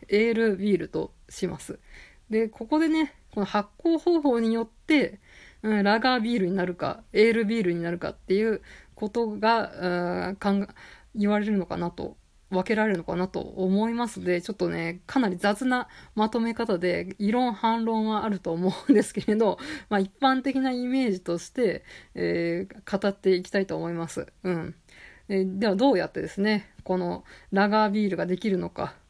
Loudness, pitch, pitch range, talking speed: -26 LUFS, 210 Hz, 185-230 Hz, 340 characters per minute